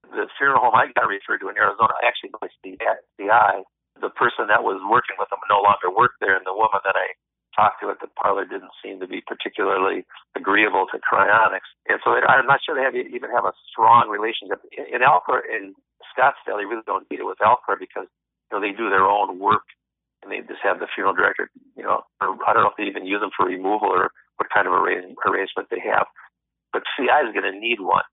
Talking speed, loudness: 235 wpm, -20 LUFS